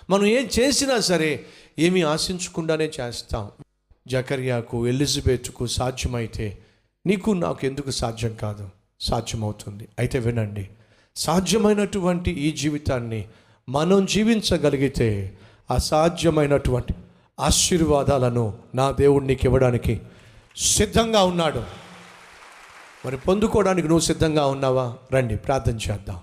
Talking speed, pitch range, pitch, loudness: 90 wpm, 110-165 Hz, 130 Hz, -22 LUFS